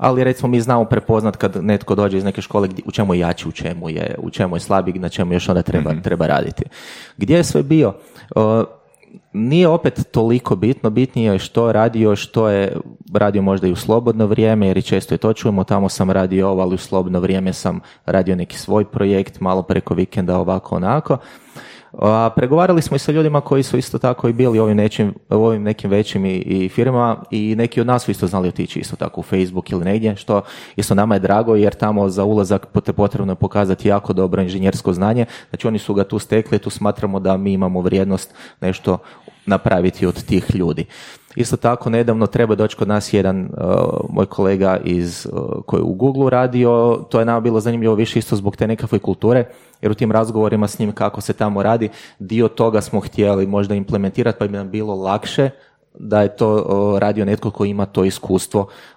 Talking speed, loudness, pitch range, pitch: 200 wpm, -17 LUFS, 95-115 Hz, 105 Hz